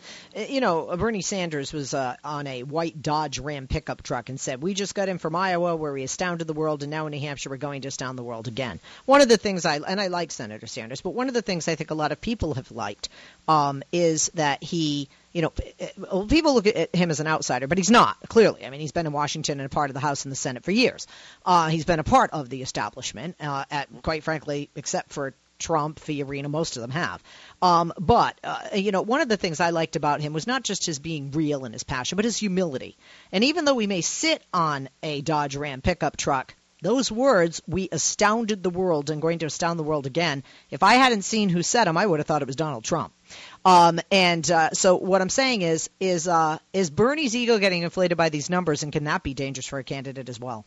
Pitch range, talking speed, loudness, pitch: 145-185 Hz, 250 wpm, -24 LUFS, 160 Hz